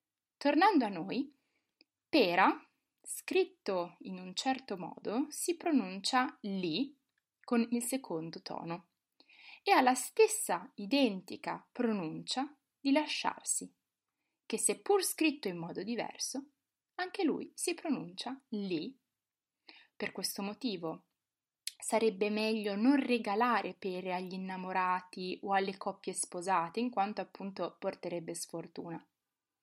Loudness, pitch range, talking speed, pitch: -34 LUFS, 190-275 Hz, 110 wpm, 220 Hz